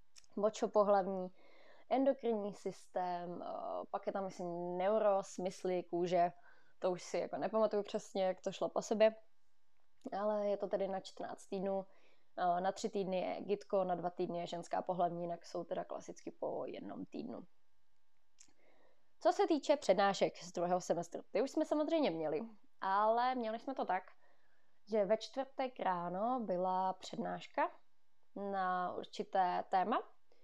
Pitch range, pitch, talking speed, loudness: 180-225 Hz, 195 Hz, 140 wpm, -38 LUFS